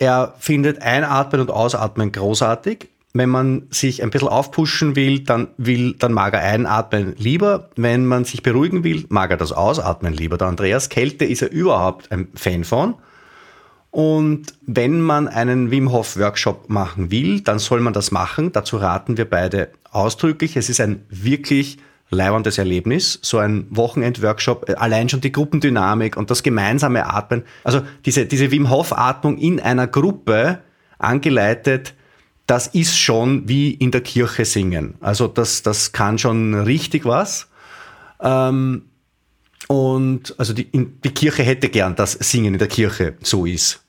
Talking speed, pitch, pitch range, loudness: 155 wpm, 125 Hz, 105-140 Hz, -18 LUFS